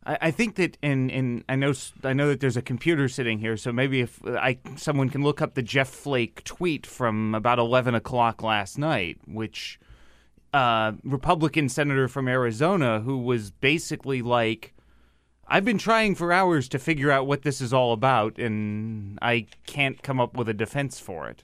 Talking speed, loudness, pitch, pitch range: 185 wpm, -25 LUFS, 130 Hz, 115-145 Hz